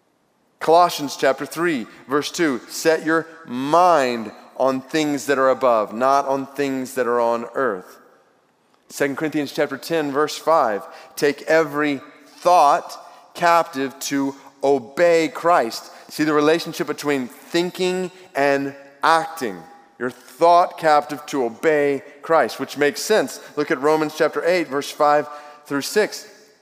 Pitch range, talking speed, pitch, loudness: 140-165 Hz, 130 wpm, 150 Hz, -20 LUFS